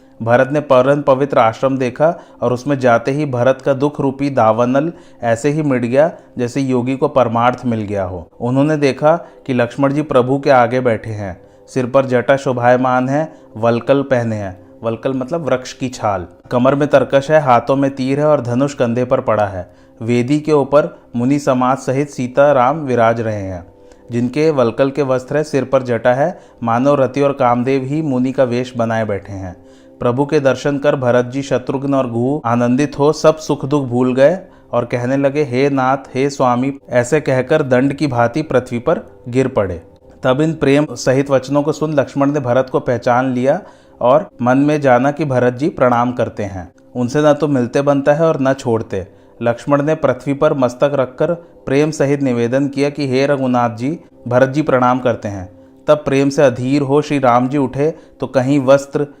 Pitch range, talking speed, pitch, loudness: 120-145 Hz, 190 wpm, 130 Hz, -15 LUFS